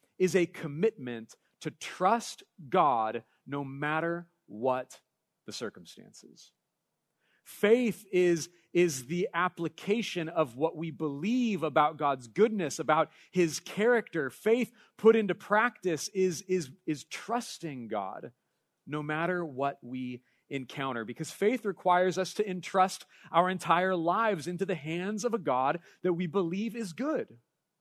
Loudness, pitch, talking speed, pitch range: -30 LUFS, 175 Hz, 130 wpm, 155-200 Hz